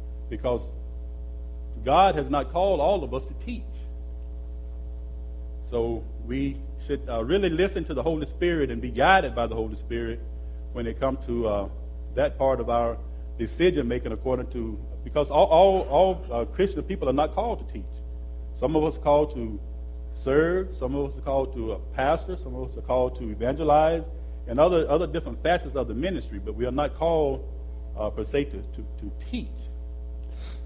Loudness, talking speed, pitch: -26 LUFS, 185 wpm, 65 Hz